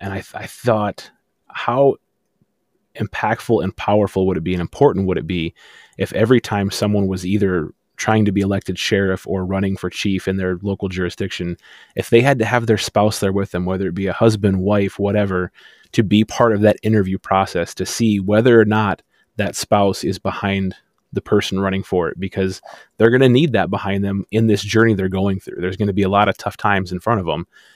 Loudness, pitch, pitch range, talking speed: -18 LUFS, 100 Hz, 95-110 Hz, 215 wpm